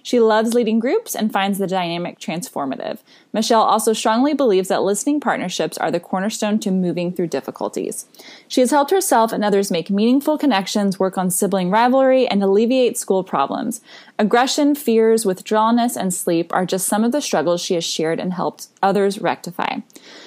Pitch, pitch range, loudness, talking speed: 215 Hz, 190-250 Hz, -18 LUFS, 170 wpm